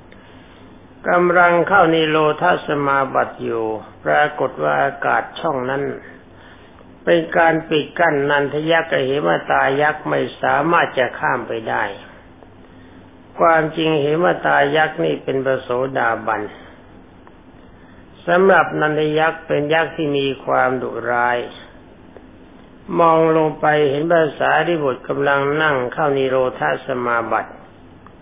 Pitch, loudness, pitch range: 140 Hz, -17 LUFS, 95-155 Hz